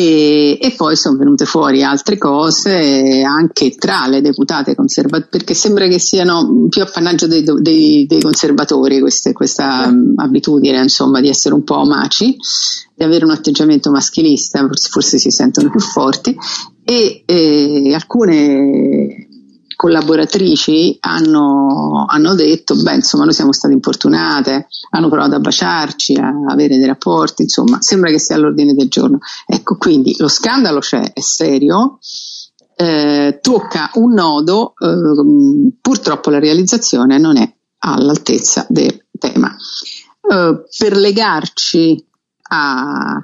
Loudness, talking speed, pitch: -11 LUFS, 135 wpm, 185 Hz